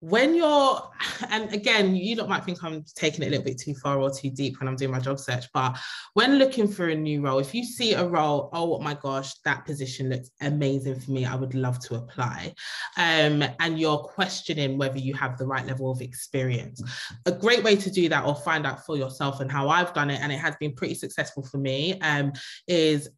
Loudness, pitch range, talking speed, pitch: -26 LUFS, 135-175 Hz, 230 wpm, 145 Hz